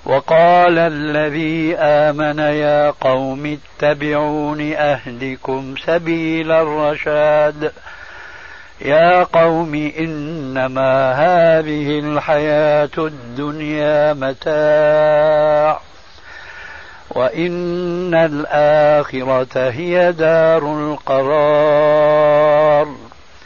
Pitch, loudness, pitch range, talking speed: 150 Hz, -15 LUFS, 150-160 Hz, 55 wpm